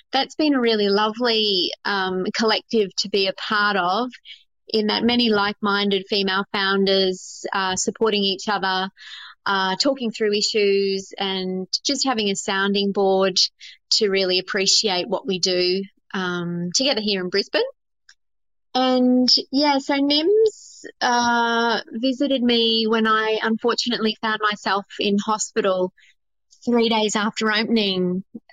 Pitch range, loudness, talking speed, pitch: 195-235 Hz, -20 LUFS, 130 wpm, 210 Hz